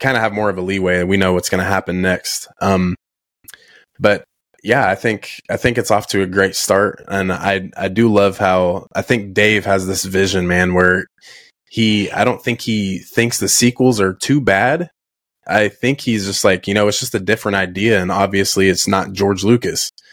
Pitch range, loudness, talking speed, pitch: 95-110 Hz, -16 LUFS, 210 wpm, 100 Hz